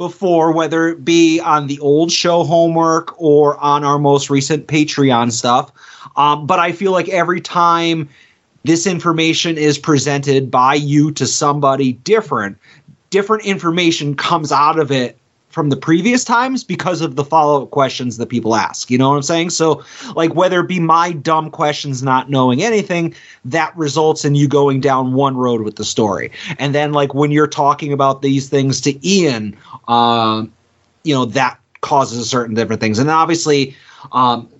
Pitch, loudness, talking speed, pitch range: 150 Hz, -14 LUFS, 175 wpm, 135-165 Hz